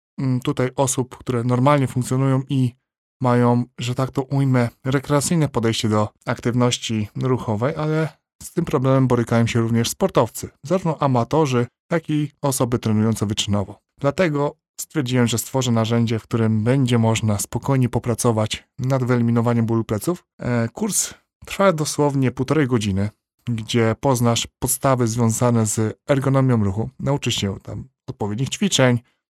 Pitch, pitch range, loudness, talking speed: 125 Hz, 115-140 Hz, -20 LUFS, 130 wpm